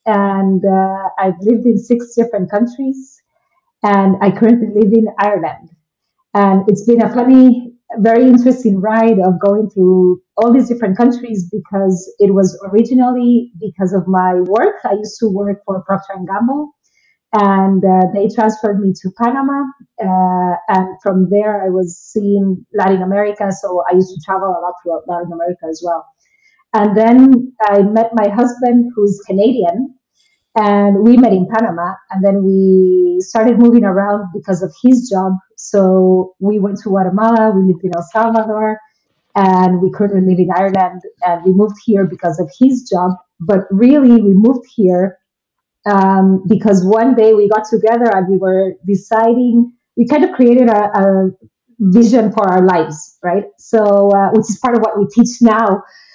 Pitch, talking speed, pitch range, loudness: 205 Hz, 170 wpm, 190-230 Hz, -12 LUFS